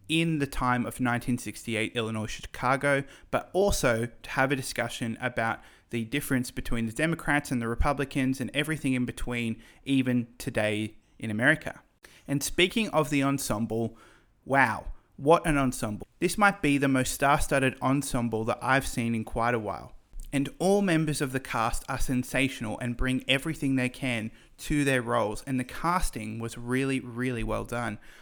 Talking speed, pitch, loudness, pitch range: 165 wpm, 130 Hz, -28 LUFS, 115-140 Hz